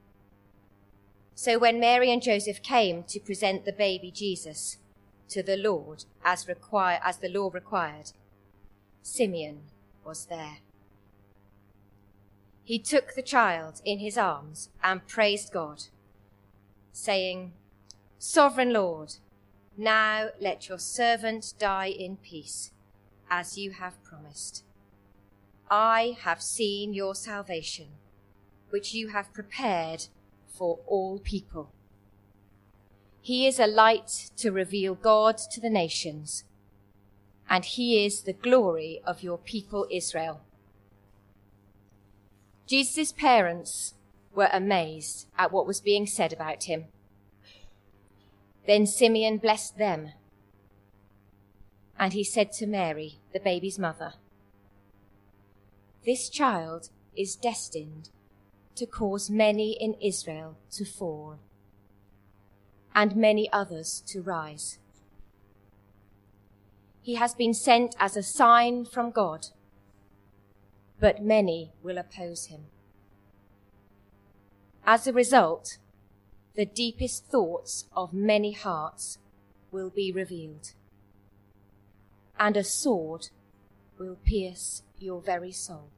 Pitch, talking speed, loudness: 160 Hz, 105 wpm, -27 LUFS